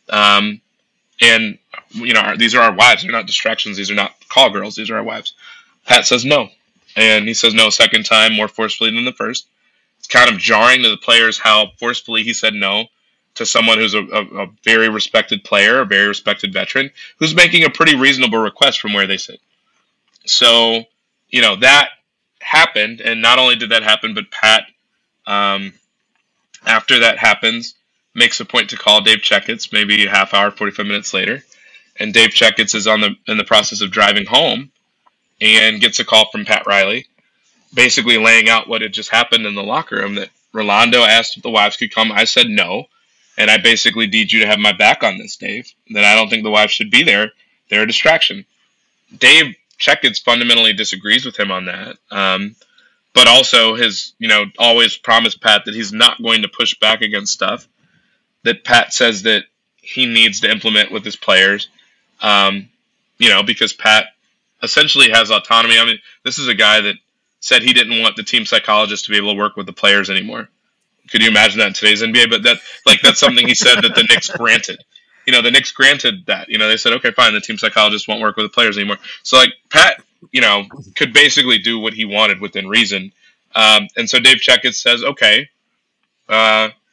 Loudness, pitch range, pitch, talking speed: -11 LUFS, 105-115 Hz, 110 Hz, 205 wpm